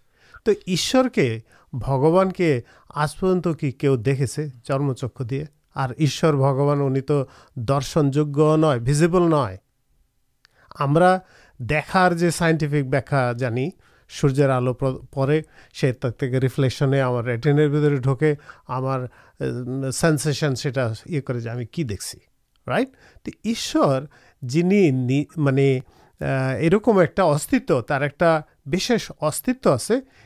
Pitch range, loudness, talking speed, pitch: 130-165 Hz, -21 LUFS, 80 wpm, 145 Hz